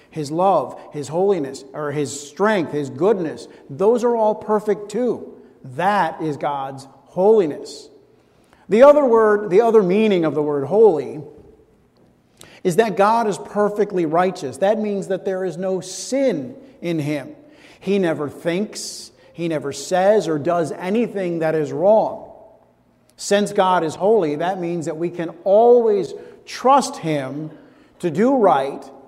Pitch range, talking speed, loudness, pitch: 160-225 Hz, 145 wpm, -19 LUFS, 190 Hz